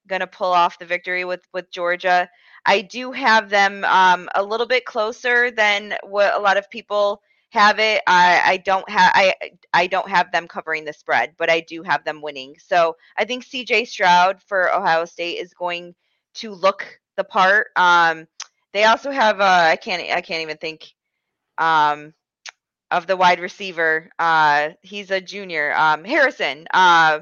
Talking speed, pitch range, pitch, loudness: 180 wpm, 165-205 Hz, 180 Hz, -18 LUFS